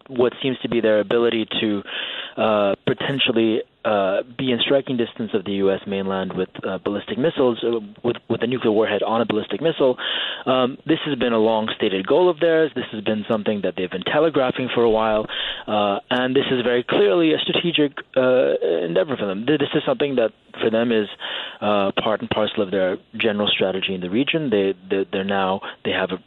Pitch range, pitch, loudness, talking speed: 105-130 Hz, 115 Hz, -21 LUFS, 205 wpm